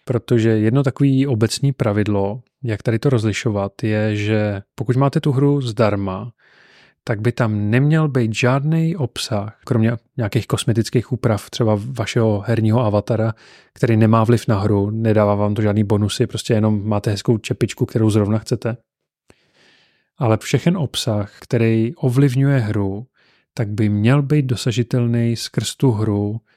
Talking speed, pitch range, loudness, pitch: 140 wpm, 110-125 Hz, -18 LUFS, 115 Hz